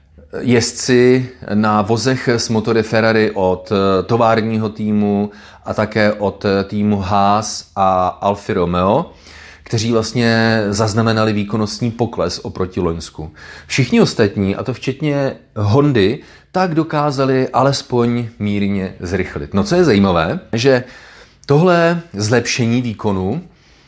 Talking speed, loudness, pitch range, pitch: 110 wpm, -16 LUFS, 100-120 Hz, 110 Hz